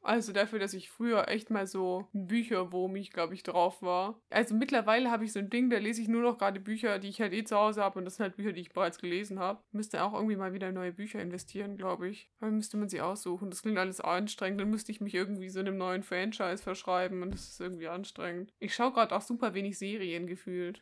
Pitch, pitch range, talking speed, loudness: 195 Hz, 185-215 Hz, 255 wpm, -34 LUFS